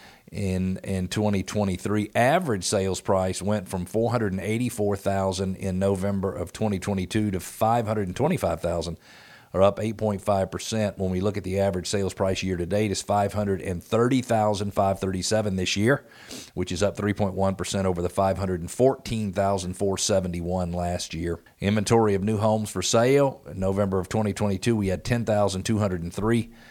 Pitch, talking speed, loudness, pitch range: 100 Hz, 125 wpm, -25 LUFS, 95-105 Hz